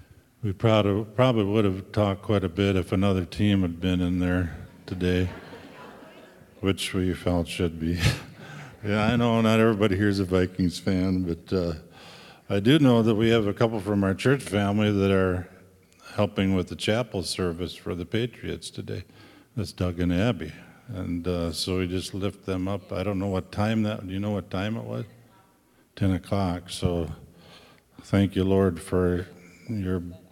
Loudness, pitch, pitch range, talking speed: -26 LUFS, 95 Hz, 90-105 Hz, 175 wpm